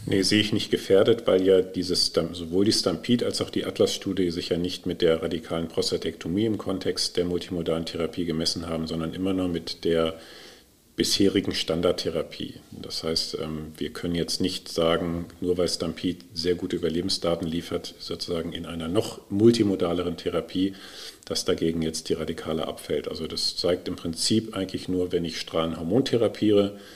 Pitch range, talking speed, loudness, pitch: 80-95 Hz, 160 wpm, -26 LUFS, 90 Hz